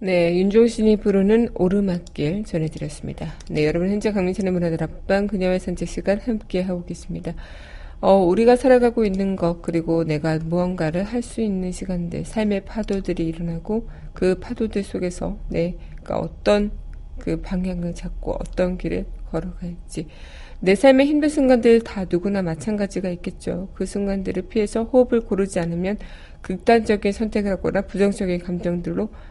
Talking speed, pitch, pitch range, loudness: 340 characters per minute, 185 Hz, 175-210 Hz, -21 LUFS